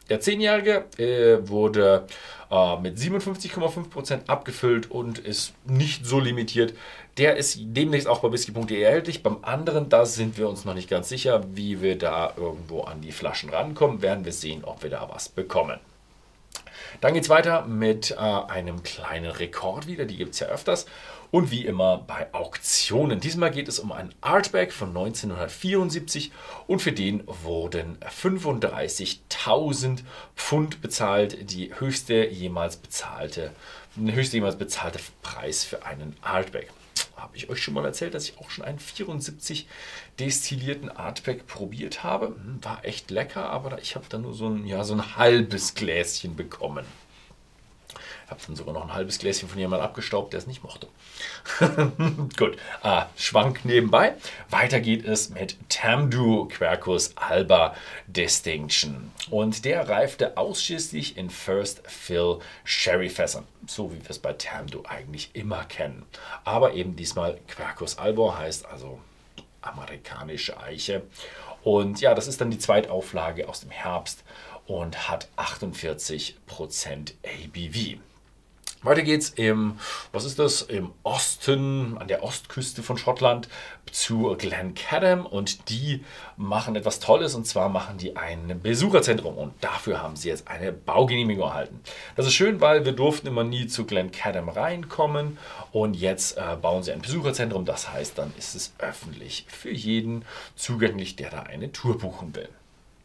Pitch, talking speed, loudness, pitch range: 115 Hz, 150 wpm, -26 LUFS, 95-140 Hz